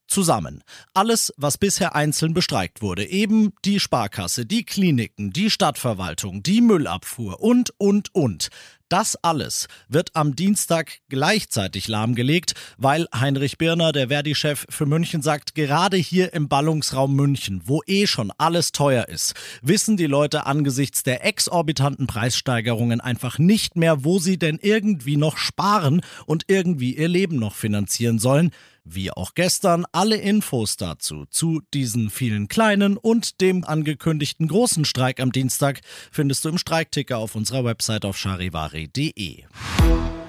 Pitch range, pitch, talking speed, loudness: 120-180 Hz, 150 Hz, 140 wpm, -21 LUFS